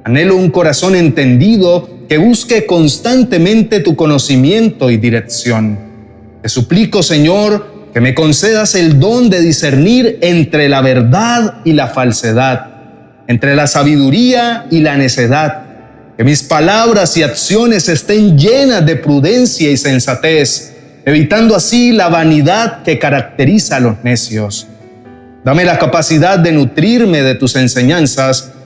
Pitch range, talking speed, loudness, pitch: 130-190 Hz, 130 wpm, -9 LUFS, 150 Hz